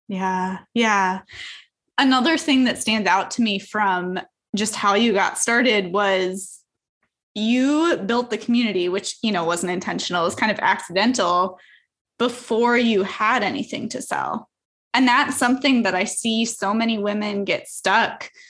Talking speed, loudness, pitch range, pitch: 150 wpm, -20 LUFS, 190-245 Hz, 215 Hz